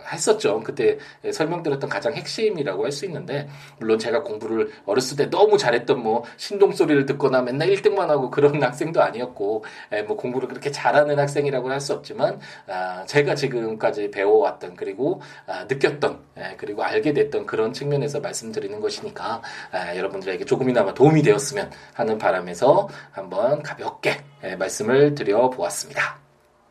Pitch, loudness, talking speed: 145 Hz, -22 LUFS, 355 characters per minute